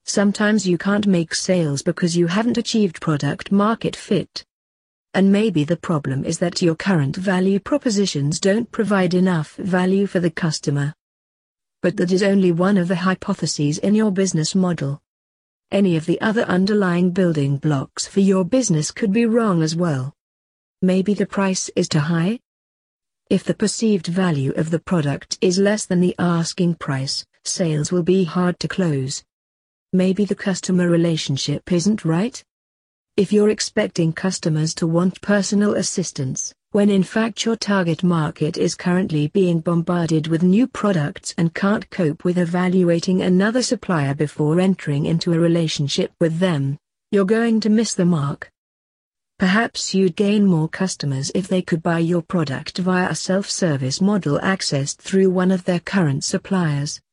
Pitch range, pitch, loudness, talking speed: 160-195 Hz, 180 Hz, -19 LUFS, 160 wpm